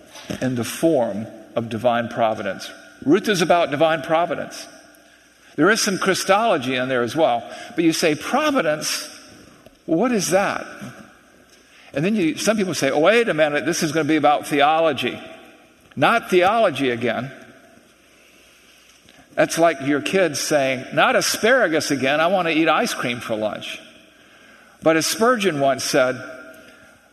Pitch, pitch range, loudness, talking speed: 160 Hz, 130-195 Hz, -19 LUFS, 150 wpm